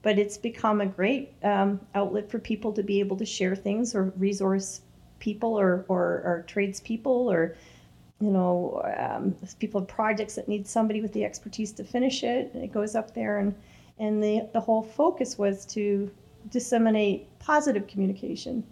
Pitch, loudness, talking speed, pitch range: 210 Hz, -28 LUFS, 170 wpm, 195-225 Hz